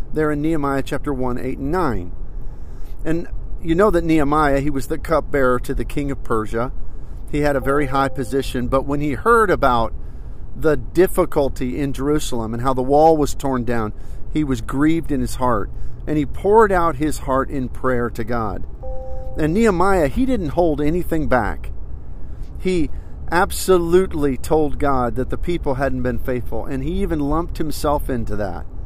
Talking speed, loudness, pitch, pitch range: 175 wpm, -20 LUFS, 135 Hz, 120-155 Hz